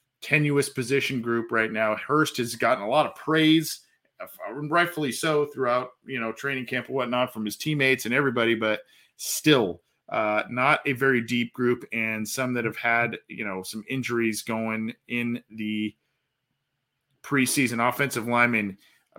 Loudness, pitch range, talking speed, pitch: -25 LUFS, 110-140 Hz, 155 wpm, 125 Hz